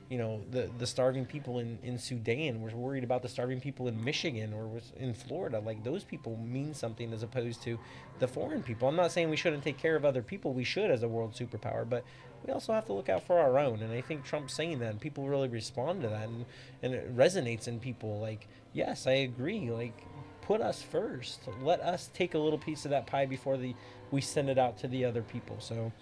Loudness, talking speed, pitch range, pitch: -34 LUFS, 240 wpm, 115-140 Hz, 125 Hz